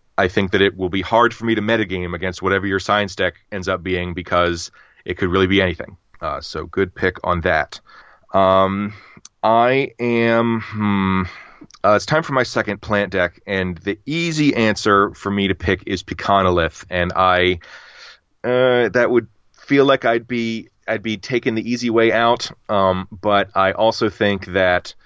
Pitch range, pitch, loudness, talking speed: 95-115 Hz, 100 Hz, -18 LUFS, 180 wpm